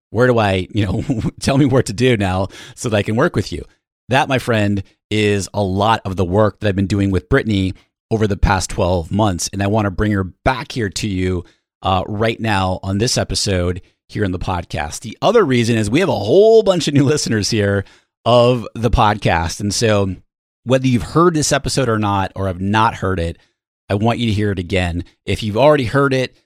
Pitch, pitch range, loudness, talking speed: 105 Hz, 95-120 Hz, -17 LUFS, 225 wpm